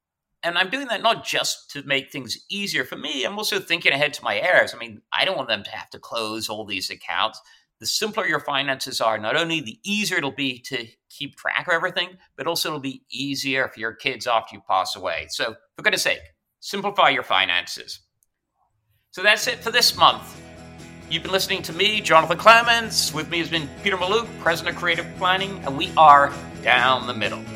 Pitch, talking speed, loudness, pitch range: 150 Hz, 210 wpm, -21 LUFS, 120-185 Hz